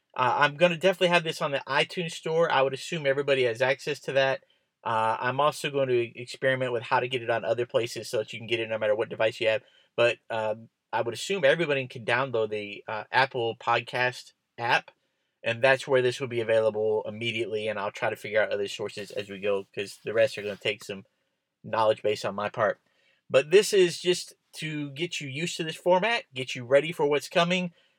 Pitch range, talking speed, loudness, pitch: 115-160 Hz, 230 wpm, -27 LUFS, 130 Hz